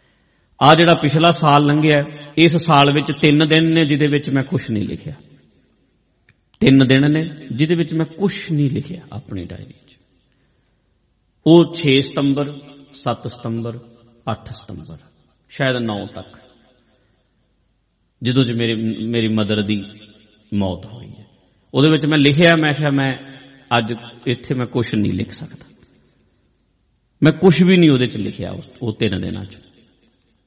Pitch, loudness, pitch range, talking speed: 135 Hz, -16 LUFS, 115-150 Hz, 145 wpm